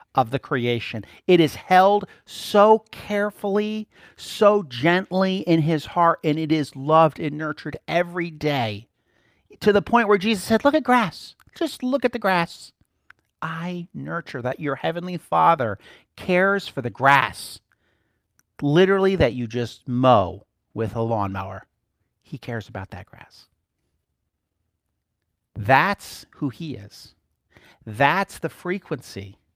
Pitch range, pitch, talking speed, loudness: 115-190 Hz, 155 Hz, 130 wpm, -21 LUFS